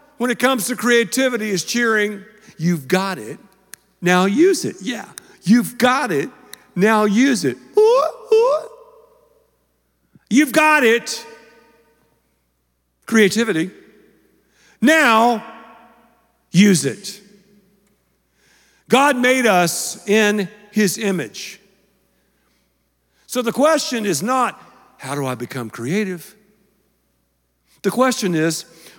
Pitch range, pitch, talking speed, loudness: 180-245 Hz, 210 Hz, 100 wpm, -17 LUFS